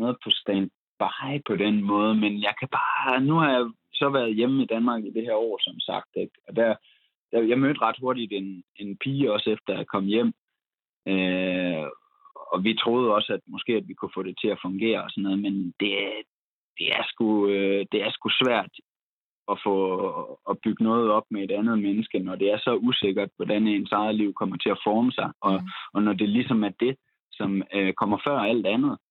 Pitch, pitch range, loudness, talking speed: 105 Hz, 100-120 Hz, -25 LUFS, 210 wpm